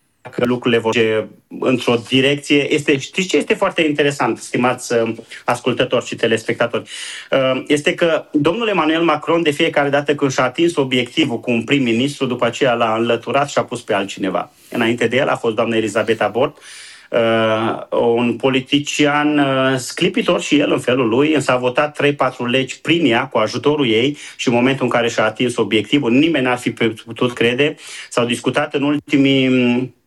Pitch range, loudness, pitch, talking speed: 120-145 Hz, -17 LUFS, 130 Hz, 165 wpm